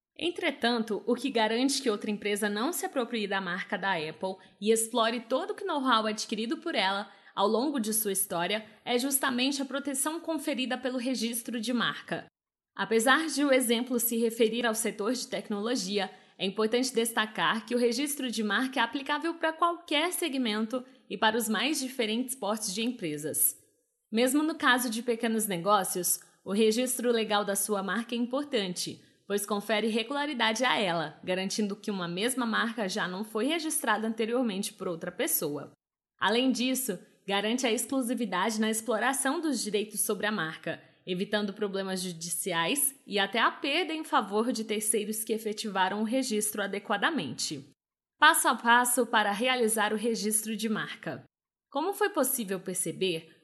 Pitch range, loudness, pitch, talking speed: 205-255 Hz, -29 LUFS, 225 Hz, 155 wpm